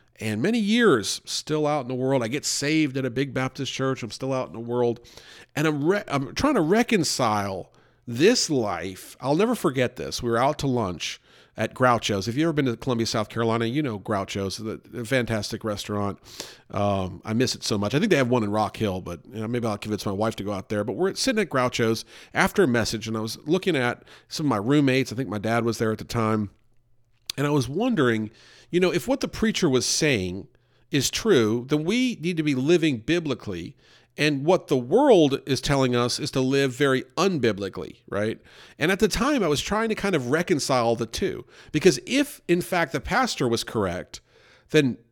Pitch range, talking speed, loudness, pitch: 110-155 Hz, 220 wpm, -24 LUFS, 130 Hz